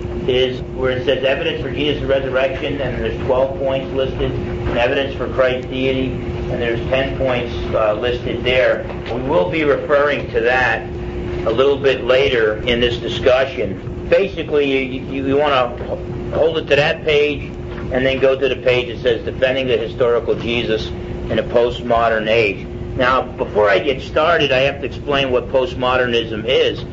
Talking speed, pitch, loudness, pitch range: 170 wpm, 130 Hz, -17 LUFS, 120-135 Hz